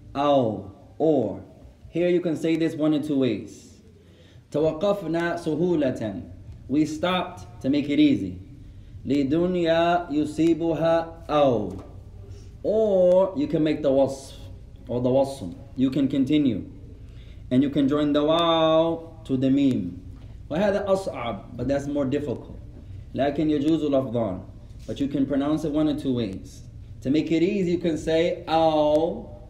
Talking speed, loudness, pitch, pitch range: 125 wpm, -24 LUFS, 140 Hz, 110-165 Hz